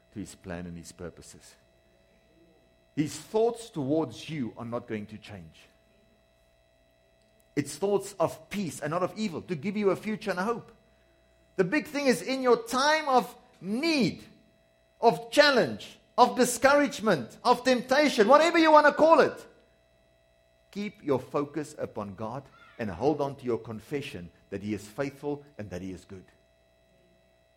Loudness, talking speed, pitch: -27 LUFS, 155 wpm, 145 Hz